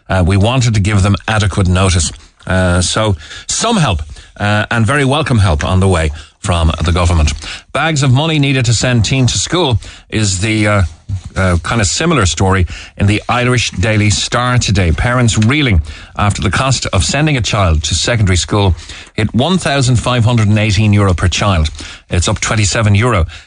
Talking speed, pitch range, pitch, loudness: 170 wpm, 90-115 Hz, 100 Hz, -13 LUFS